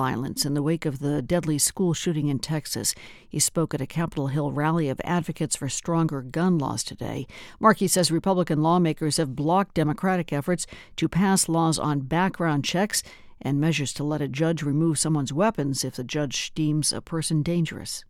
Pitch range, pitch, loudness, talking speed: 145-170 Hz, 155 Hz, -25 LUFS, 180 wpm